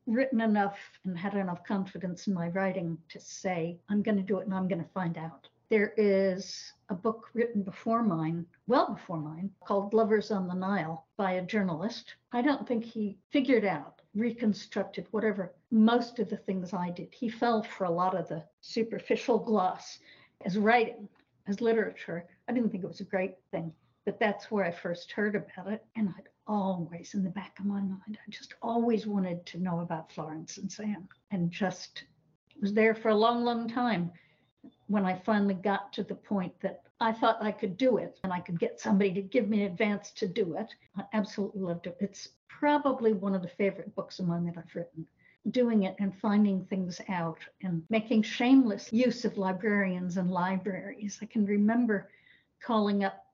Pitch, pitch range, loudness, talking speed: 200 Hz, 185-220 Hz, -31 LUFS, 195 wpm